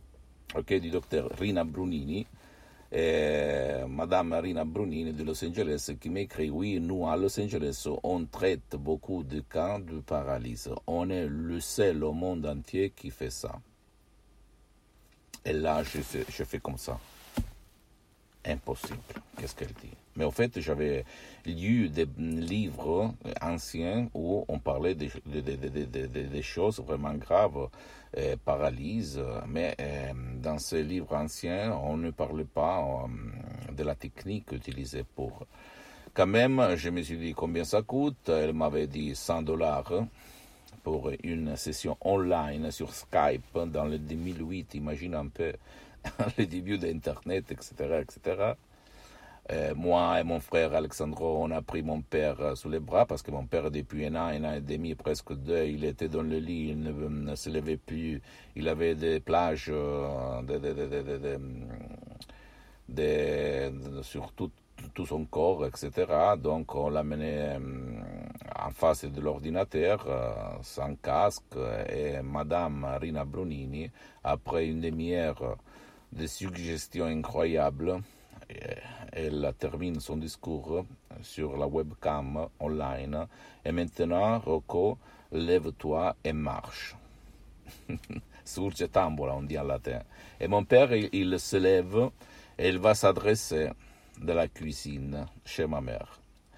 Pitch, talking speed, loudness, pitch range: 80 Hz, 140 wpm, -32 LUFS, 75-85 Hz